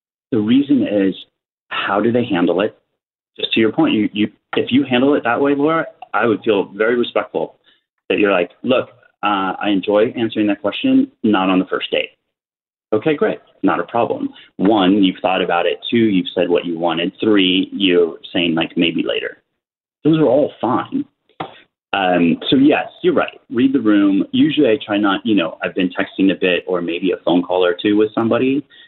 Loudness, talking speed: -17 LUFS, 195 wpm